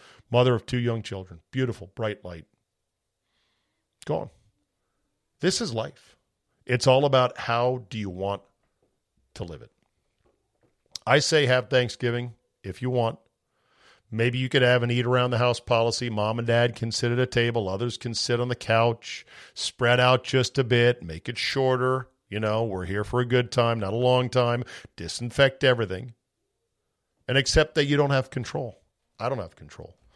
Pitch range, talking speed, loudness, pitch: 115-125 Hz, 175 wpm, -25 LUFS, 120 Hz